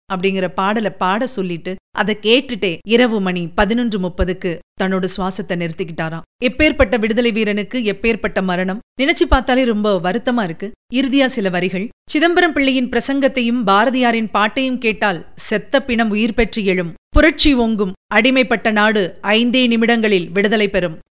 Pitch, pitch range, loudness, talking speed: 215 Hz, 190-245 Hz, -16 LUFS, 125 wpm